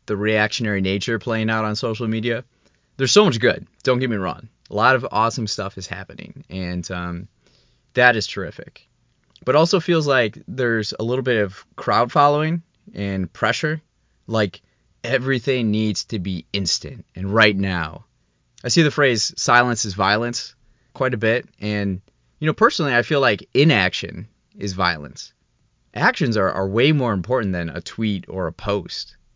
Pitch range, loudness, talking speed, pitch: 95-125 Hz, -20 LUFS, 170 wpm, 110 Hz